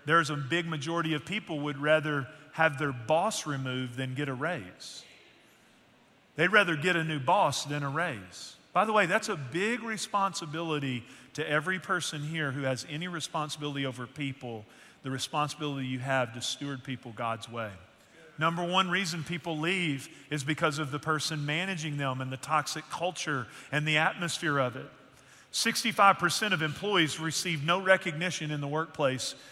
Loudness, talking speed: -30 LUFS, 165 wpm